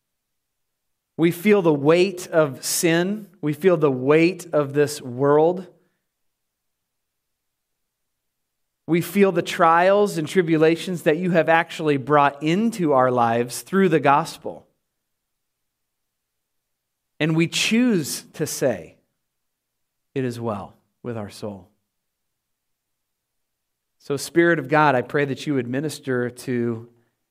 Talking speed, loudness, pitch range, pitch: 115 wpm, -20 LUFS, 130-170 Hz, 150 Hz